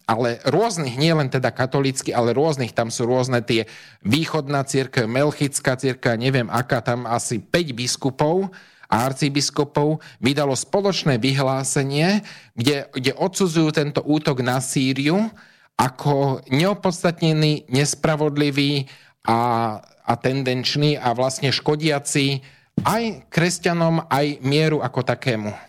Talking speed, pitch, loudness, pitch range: 110 wpm, 140 Hz, -21 LUFS, 130-155 Hz